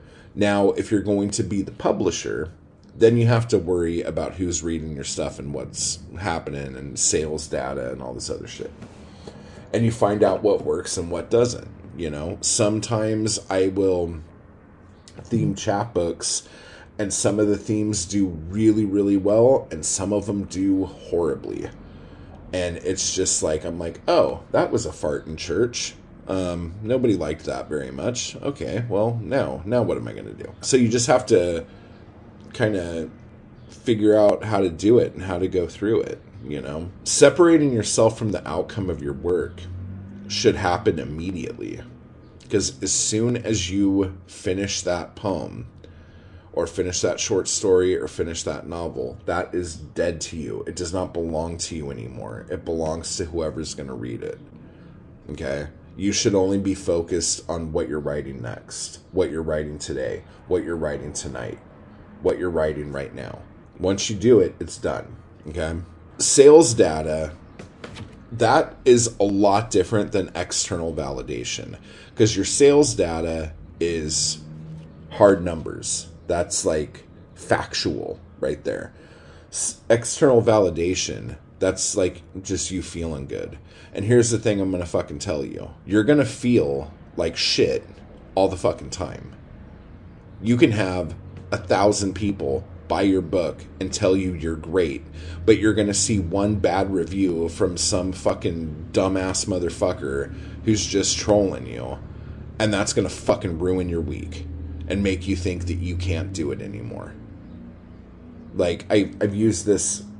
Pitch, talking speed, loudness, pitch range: 95 Hz, 155 wpm, -22 LUFS, 80-105 Hz